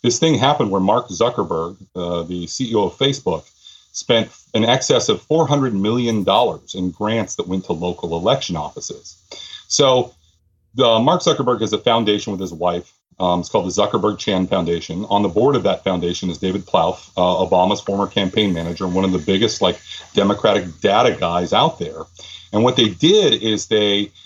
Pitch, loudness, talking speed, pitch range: 95 Hz, -18 LUFS, 180 wpm, 90-110 Hz